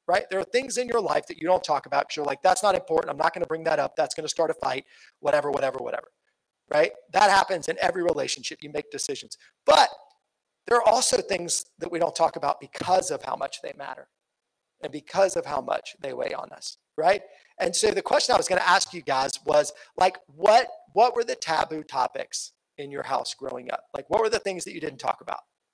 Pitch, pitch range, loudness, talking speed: 170 Hz, 150-200 Hz, -25 LUFS, 240 wpm